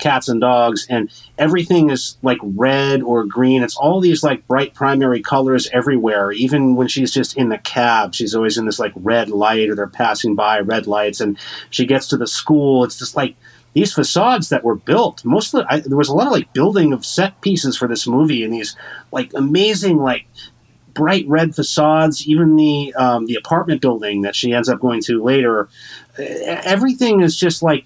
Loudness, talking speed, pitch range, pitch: -16 LUFS, 200 wpm, 115-150 Hz, 130 Hz